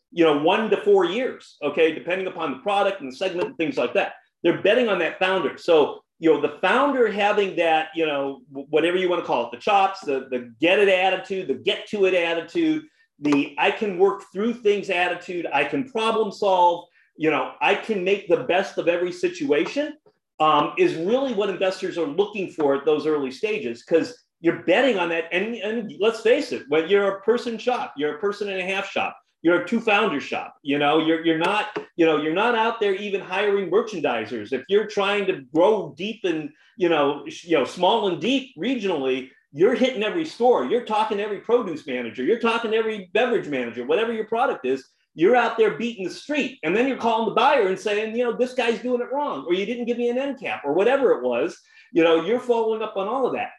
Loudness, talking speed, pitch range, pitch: -22 LUFS, 225 wpm, 165-235 Hz, 200 Hz